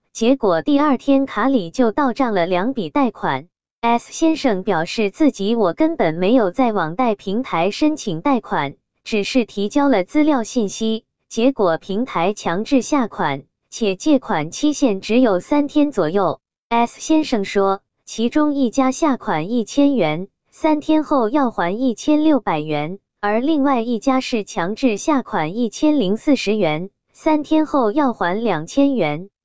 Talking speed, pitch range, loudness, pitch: 225 characters per minute, 200-280 Hz, -19 LUFS, 235 Hz